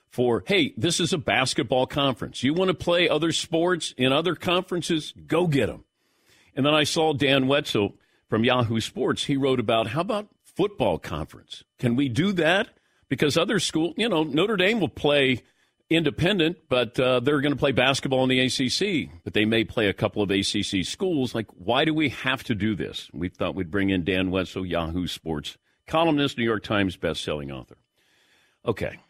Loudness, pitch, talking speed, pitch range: -24 LUFS, 130 Hz, 190 wpm, 105-155 Hz